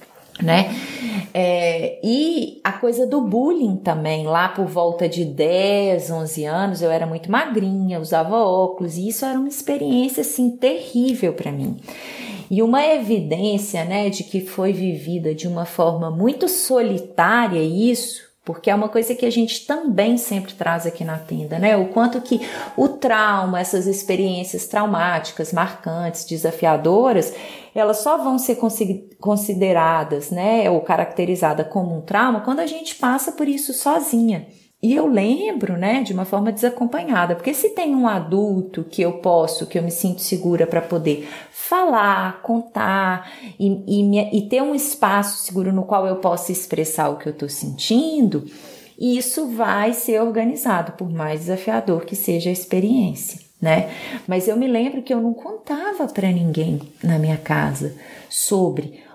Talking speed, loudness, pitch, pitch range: 155 wpm, -20 LUFS, 200 Hz, 170-240 Hz